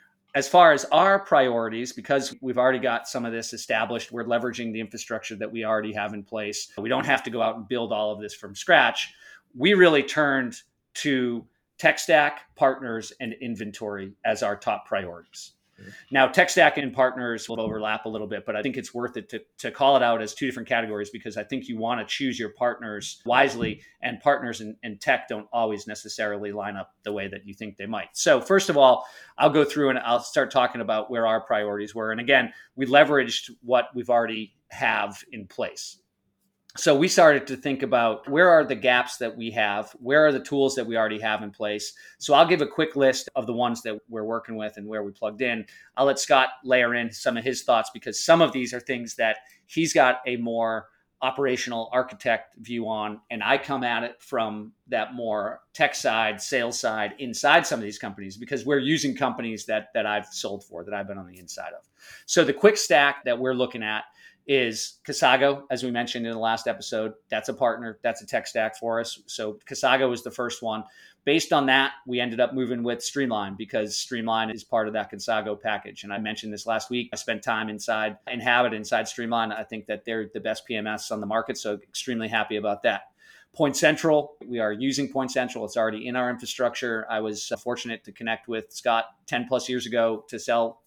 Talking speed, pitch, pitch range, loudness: 215 wpm, 115 Hz, 110-130 Hz, -24 LUFS